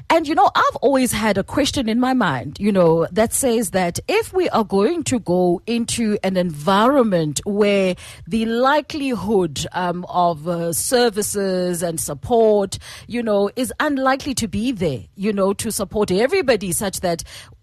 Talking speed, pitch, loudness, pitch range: 165 wpm, 205 Hz, -19 LUFS, 180-250 Hz